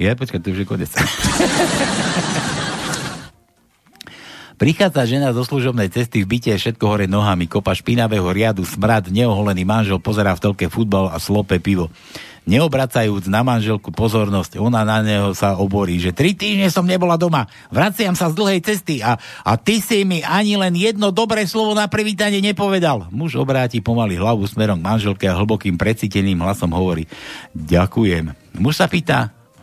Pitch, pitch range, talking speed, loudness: 110 Hz, 100-160 Hz, 160 wpm, -17 LUFS